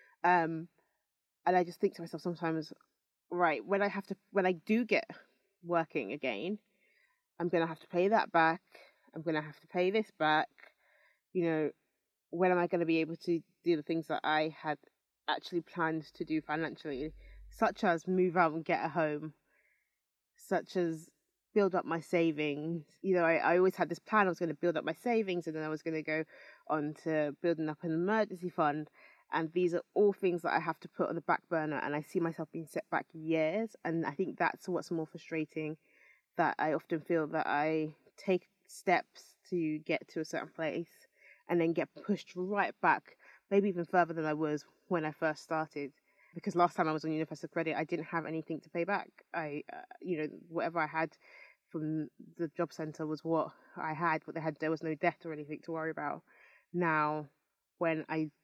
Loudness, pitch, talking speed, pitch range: -34 LUFS, 165 Hz, 205 wpm, 155-180 Hz